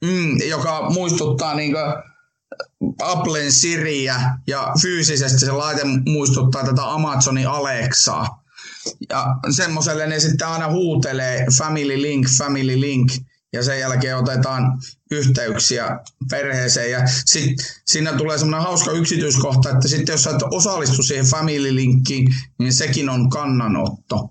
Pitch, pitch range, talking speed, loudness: 140 Hz, 130-155 Hz, 125 wpm, -18 LUFS